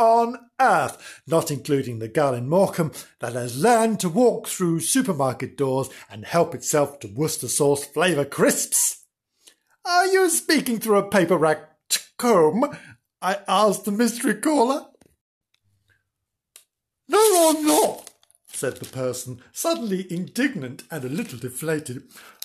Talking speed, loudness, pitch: 130 wpm, -22 LUFS, 175 Hz